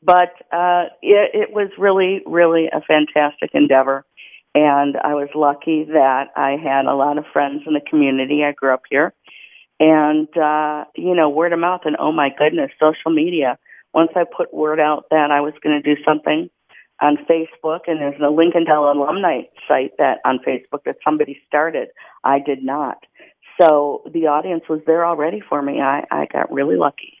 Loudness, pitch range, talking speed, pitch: -17 LUFS, 145-165 Hz, 185 wpm, 150 Hz